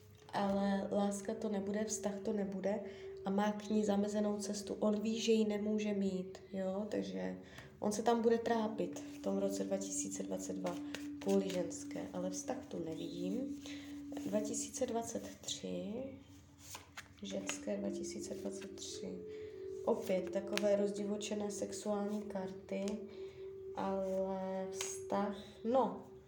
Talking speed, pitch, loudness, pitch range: 105 wpm, 200 Hz, -39 LUFS, 145-220 Hz